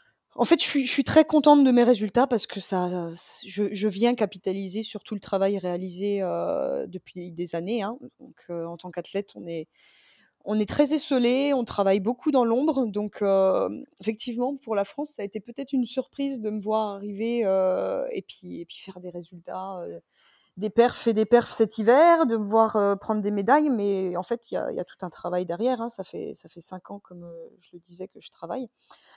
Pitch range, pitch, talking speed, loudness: 190-245 Hz, 215 Hz, 225 wpm, -24 LUFS